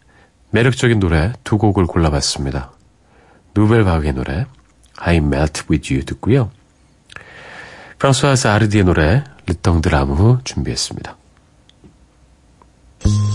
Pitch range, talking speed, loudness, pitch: 70-110 Hz, 295 characters per minute, -16 LUFS, 85 Hz